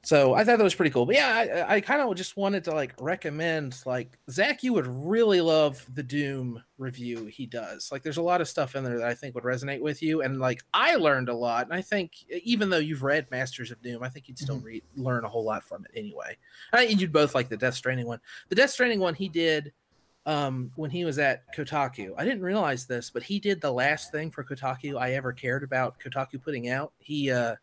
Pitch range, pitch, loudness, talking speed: 125-175 Hz, 140 Hz, -27 LUFS, 245 wpm